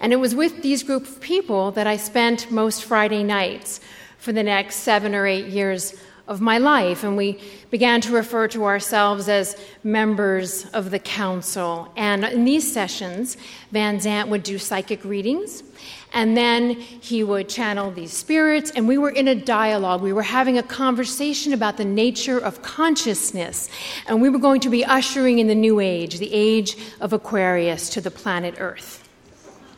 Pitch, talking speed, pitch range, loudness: 215 Hz, 175 wpm, 200-245 Hz, -21 LUFS